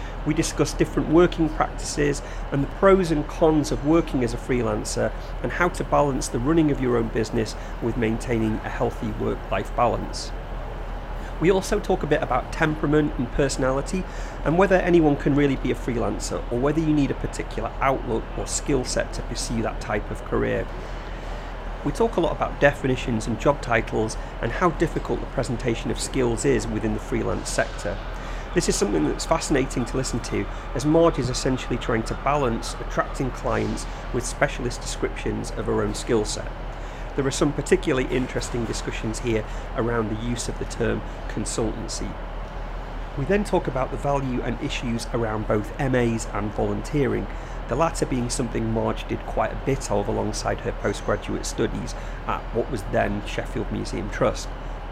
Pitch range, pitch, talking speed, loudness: 115-150 Hz, 125 Hz, 175 wpm, -25 LUFS